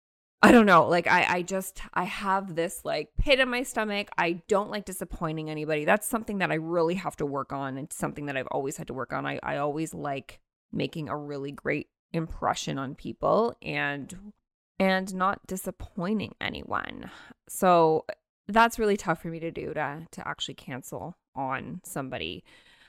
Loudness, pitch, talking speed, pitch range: -27 LUFS, 175 Hz, 180 wpm, 155-200 Hz